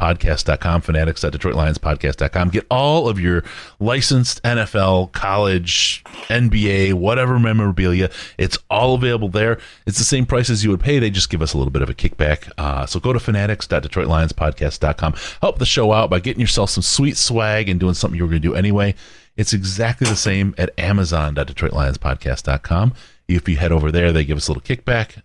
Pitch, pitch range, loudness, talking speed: 95 Hz, 80-110 Hz, -18 LUFS, 180 wpm